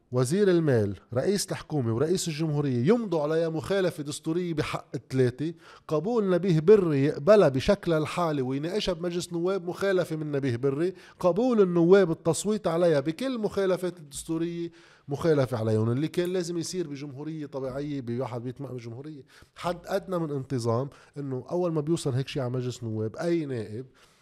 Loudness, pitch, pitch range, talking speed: -27 LUFS, 160 Hz, 135-175 Hz, 145 wpm